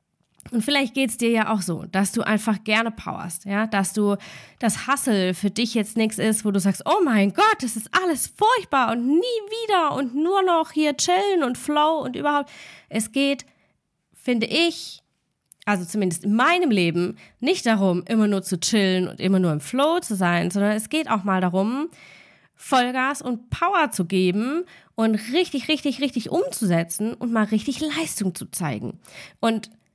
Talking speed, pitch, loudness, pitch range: 180 wpm, 225 Hz, -22 LUFS, 200-290 Hz